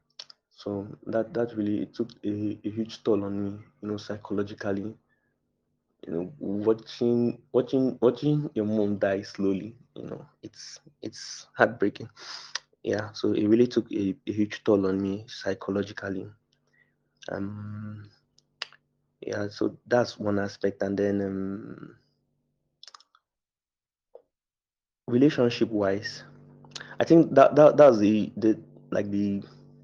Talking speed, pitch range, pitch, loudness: 120 wpm, 100-115 Hz, 105 Hz, -26 LUFS